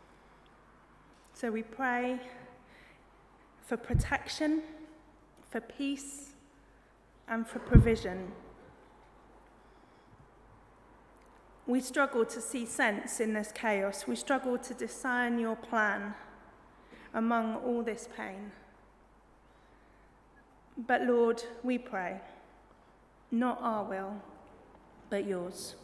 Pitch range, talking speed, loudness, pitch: 220-250 Hz, 85 wpm, -33 LUFS, 235 Hz